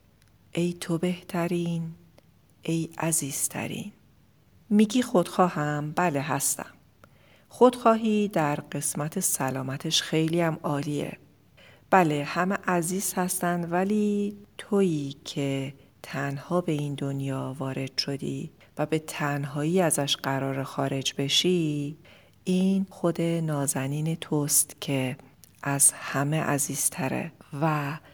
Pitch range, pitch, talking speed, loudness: 140-180 Hz, 155 Hz, 95 wpm, -26 LUFS